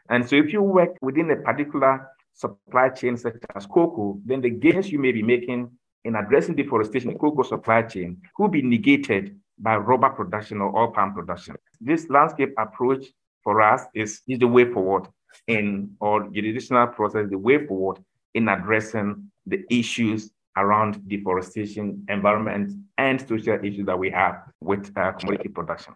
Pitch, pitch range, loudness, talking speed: 115 Hz, 105-130 Hz, -23 LUFS, 165 wpm